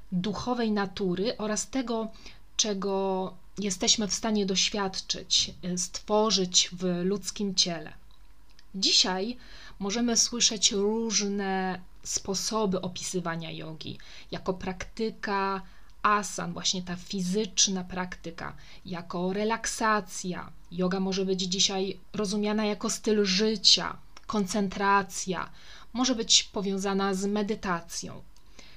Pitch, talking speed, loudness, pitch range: 195 Hz, 90 wpm, -27 LUFS, 185-215 Hz